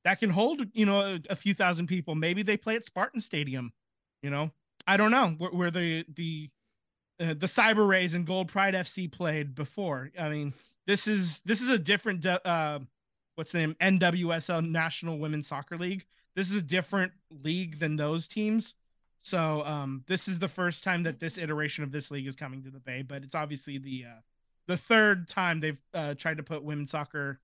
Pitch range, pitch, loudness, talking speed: 150-190 Hz, 165 Hz, -29 LUFS, 205 wpm